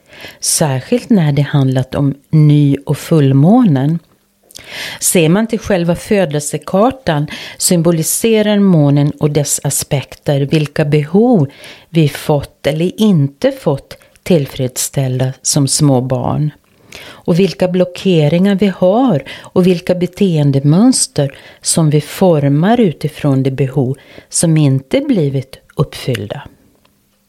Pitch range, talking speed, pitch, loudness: 140-185 Hz, 105 wpm, 155 Hz, -13 LUFS